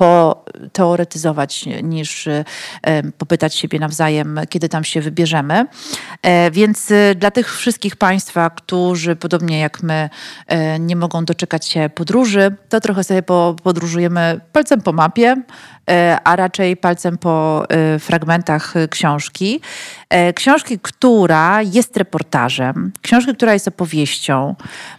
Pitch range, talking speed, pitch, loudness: 160-200 Hz, 105 wpm, 175 Hz, -15 LUFS